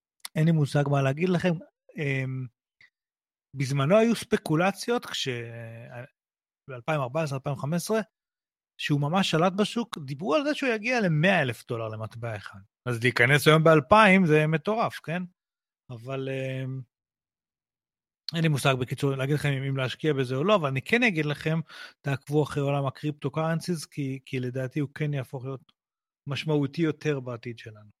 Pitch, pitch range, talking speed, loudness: 145 Hz, 130-170 Hz, 145 wpm, -26 LUFS